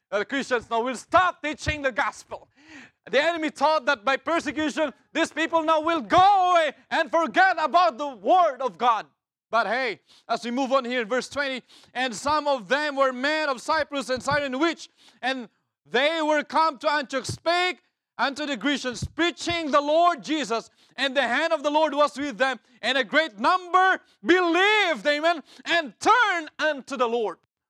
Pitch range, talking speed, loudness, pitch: 265-330 Hz, 180 wpm, -24 LUFS, 295 Hz